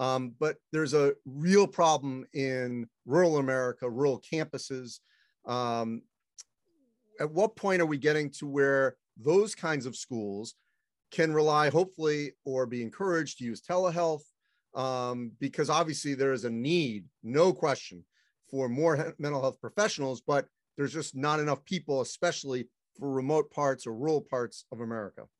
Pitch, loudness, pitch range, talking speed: 140 Hz, -30 LUFS, 130-160 Hz, 150 wpm